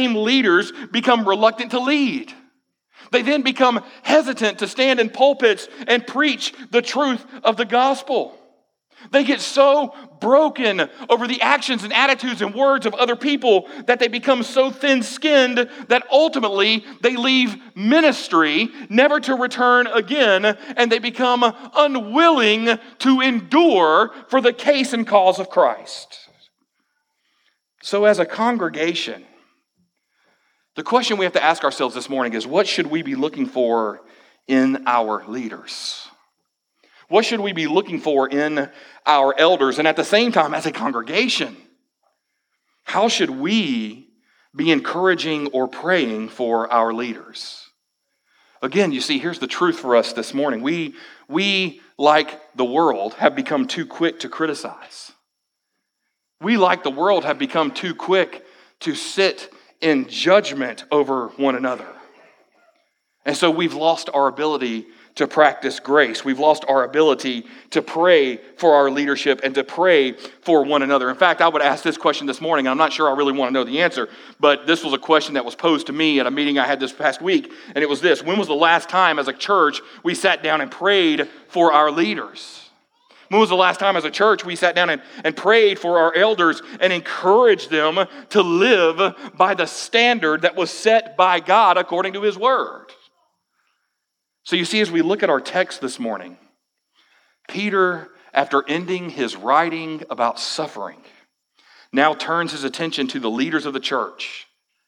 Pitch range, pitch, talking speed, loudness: 155-255 Hz, 195 Hz, 165 wpm, -18 LUFS